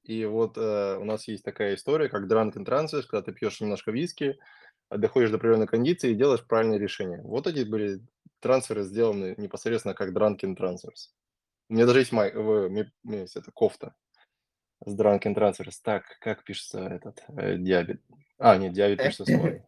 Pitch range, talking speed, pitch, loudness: 100-115 Hz, 170 wpm, 110 Hz, -27 LUFS